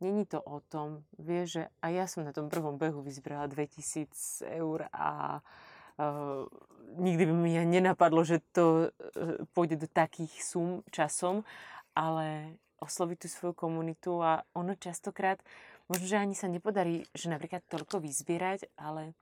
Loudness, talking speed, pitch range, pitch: -33 LUFS, 155 wpm, 155-180 Hz, 165 Hz